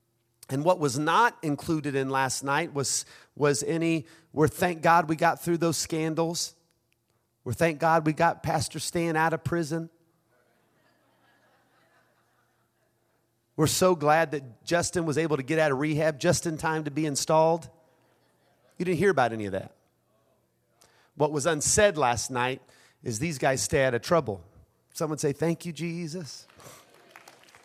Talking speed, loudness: 155 wpm, -26 LUFS